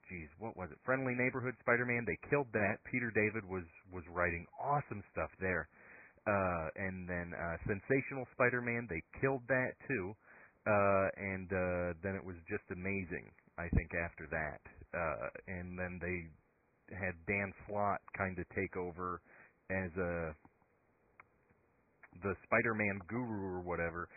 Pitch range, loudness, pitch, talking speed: 90-110 Hz, -38 LUFS, 95 Hz, 145 wpm